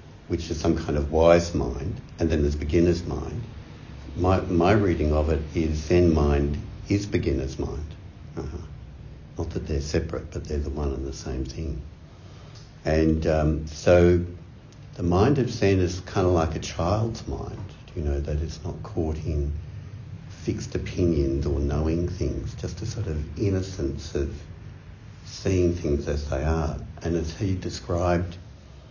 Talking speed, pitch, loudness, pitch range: 160 wpm, 85 Hz, -25 LUFS, 75-95 Hz